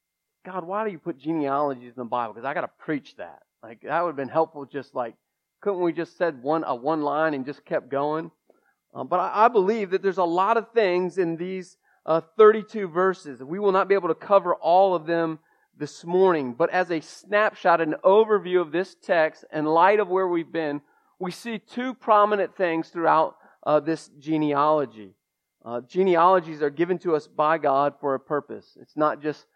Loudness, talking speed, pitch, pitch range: -23 LUFS, 205 wpm, 170 Hz, 150-190 Hz